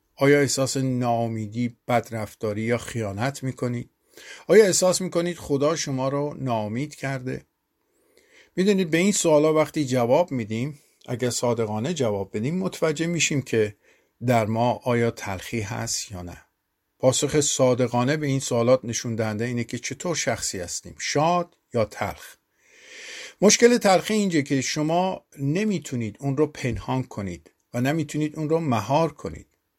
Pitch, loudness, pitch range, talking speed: 135 Hz, -24 LUFS, 115-155 Hz, 135 wpm